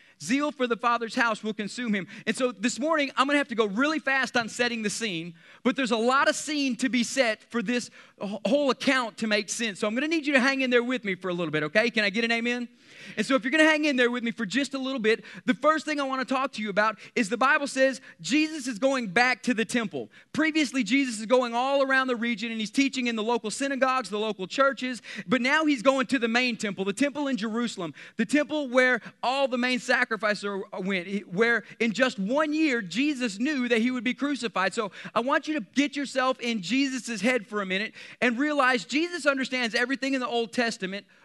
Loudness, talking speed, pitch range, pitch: -26 LUFS, 245 wpm, 220-270 Hz, 245 Hz